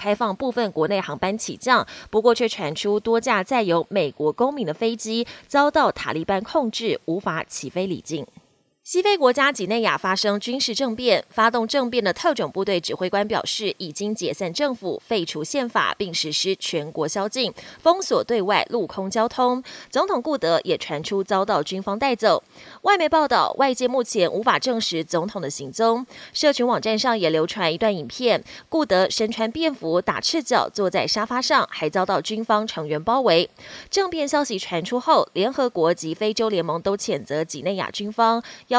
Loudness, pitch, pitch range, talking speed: -22 LUFS, 220 Hz, 185-250 Hz, 275 characters per minute